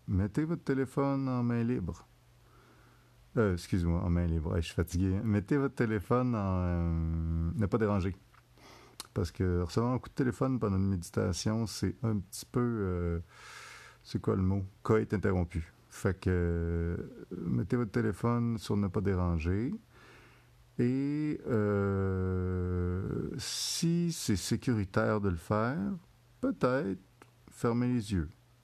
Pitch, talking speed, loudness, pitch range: 110 Hz, 140 wpm, -32 LUFS, 95-120 Hz